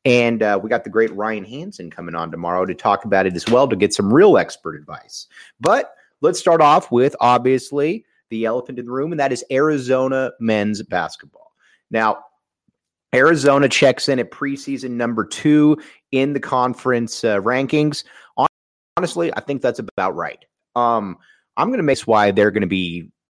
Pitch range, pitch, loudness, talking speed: 105-135 Hz, 125 Hz, -18 LUFS, 180 wpm